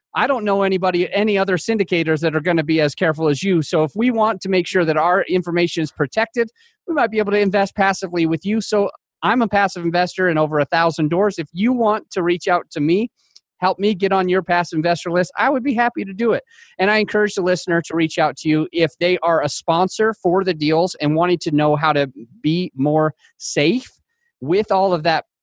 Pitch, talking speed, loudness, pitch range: 180 Hz, 240 wpm, -18 LUFS, 165-210 Hz